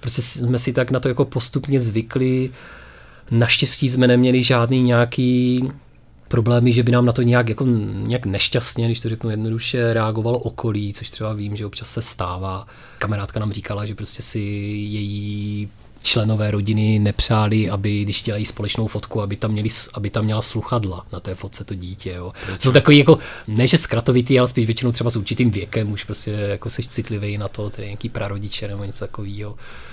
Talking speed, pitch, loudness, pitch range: 180 wpm, 110 Hz, -19 LUFS, 105-125 Hz